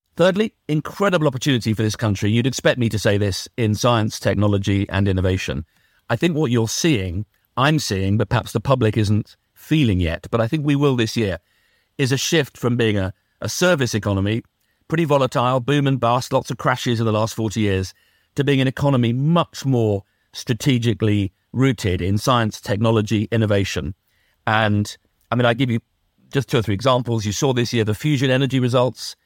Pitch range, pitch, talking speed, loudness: 105-135 Hz, 115 Hz, 185 wpm, -20 LUFS